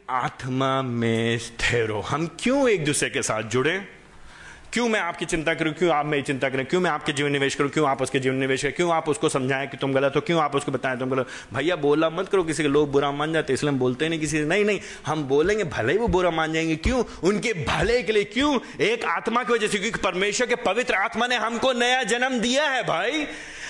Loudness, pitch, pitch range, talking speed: -23 LUFS, 160 Hz, 140-215 Hz, 235 wpm